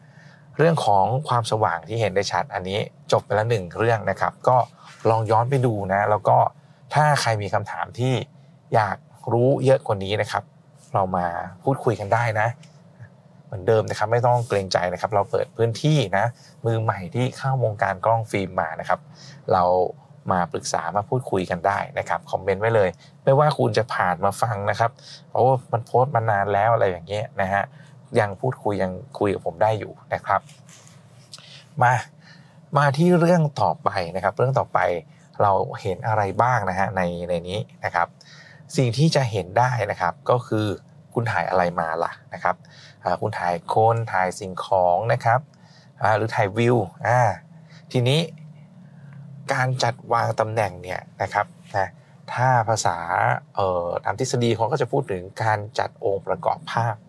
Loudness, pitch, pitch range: -22 LUFS, 115 Hz, 100-140 Hz